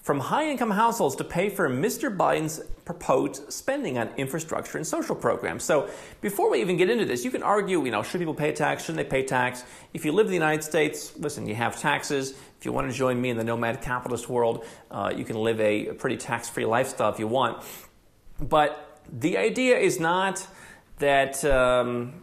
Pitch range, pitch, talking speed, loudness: 125-175 Hz, 140 Hz, 210 wpm, -26 LUFS